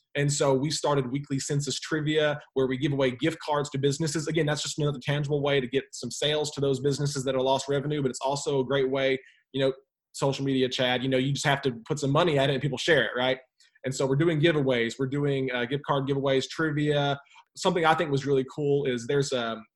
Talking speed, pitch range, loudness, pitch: 245 wpm, 135-145 Hz, -27 LUFS, 140 Hz